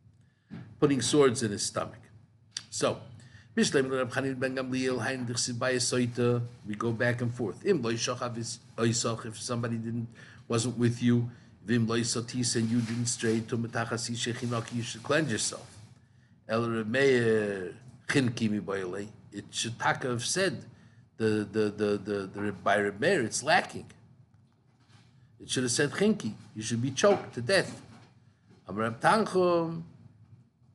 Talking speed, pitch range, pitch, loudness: 100 wpm, 115-125 Hz, 120 Hz, -29 LUFS